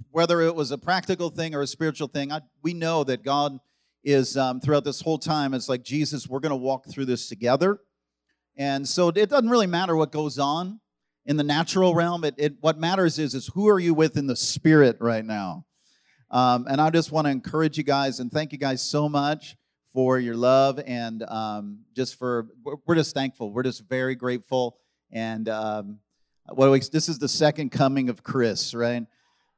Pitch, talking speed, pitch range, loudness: 140 Hz, 200 wpm, 125-155 Hz, -24 LUFS